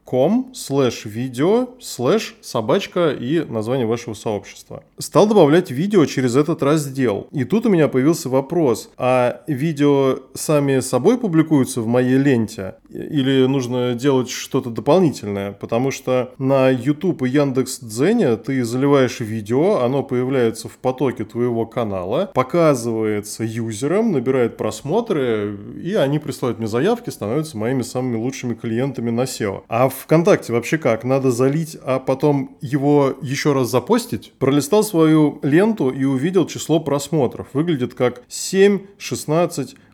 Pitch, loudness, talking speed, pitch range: 135 Hz, -19 LUFS, 130 wpm, 125-150 Hz